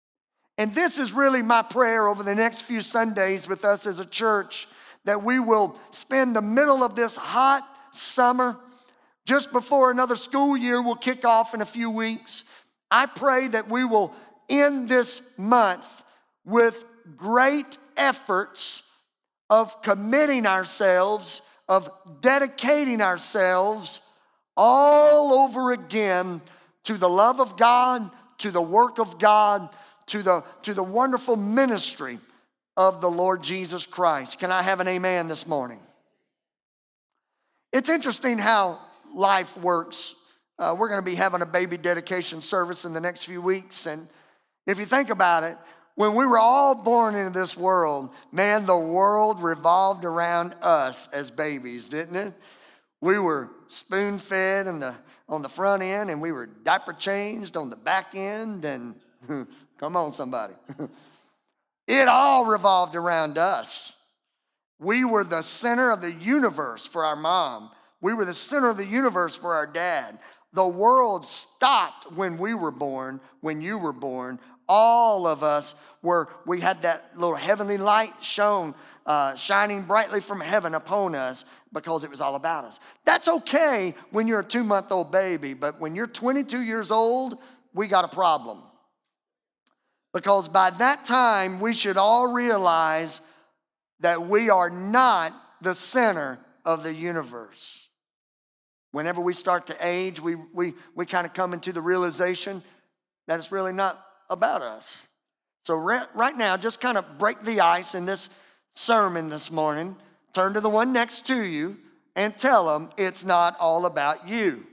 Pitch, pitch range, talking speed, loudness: 195 Hz, 175-235 Hz, 155 wpm, -23 LUFS